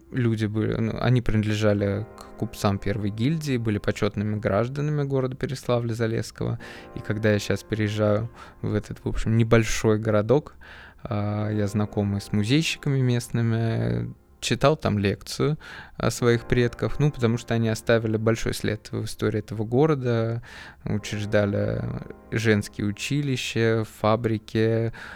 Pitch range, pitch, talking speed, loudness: 105-120 Hz, 110 Hz, 125 wpm, -25 LUFS